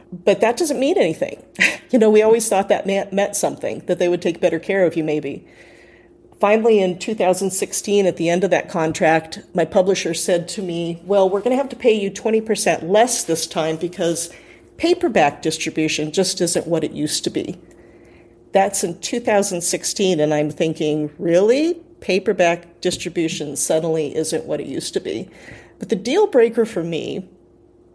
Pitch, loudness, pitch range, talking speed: 180 Hz, -19 LUFS, 165-205 Hz, 170 wpm